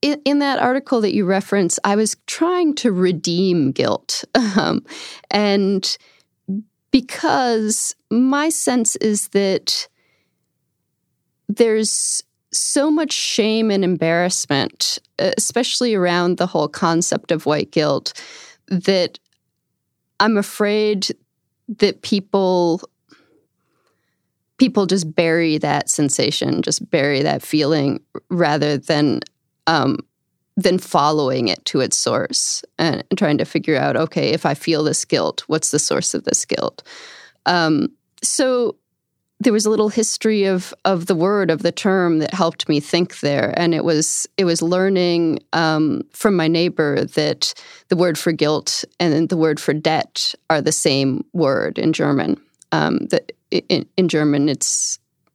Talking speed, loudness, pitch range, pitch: 135 wpm, -18 LUFS, 165-225 Hz, 190 Hz